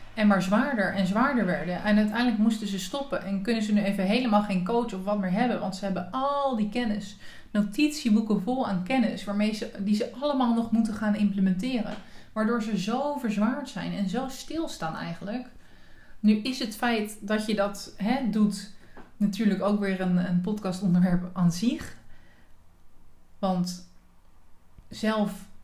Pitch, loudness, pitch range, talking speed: 210 Hz, -27 LUFS, 195-235 Hz, 165 wpm